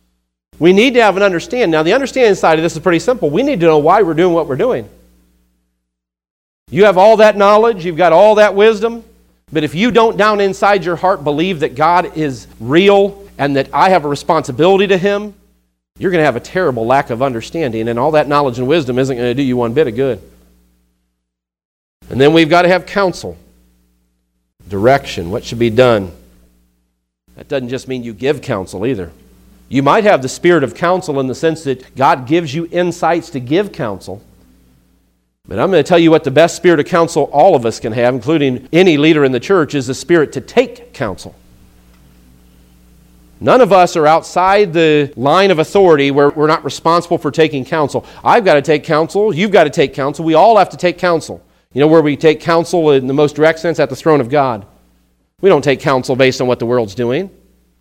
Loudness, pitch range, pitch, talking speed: -12 LUFS, 115-175 Hz, 145 Hz, 215 wpm